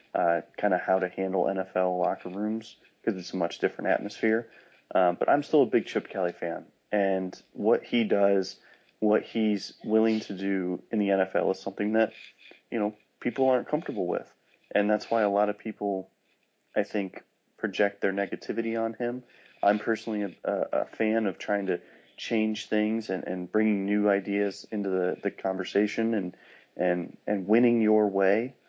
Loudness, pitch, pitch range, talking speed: -28 LUFS, 105 Hz, 95-110 Hz, 175 wpm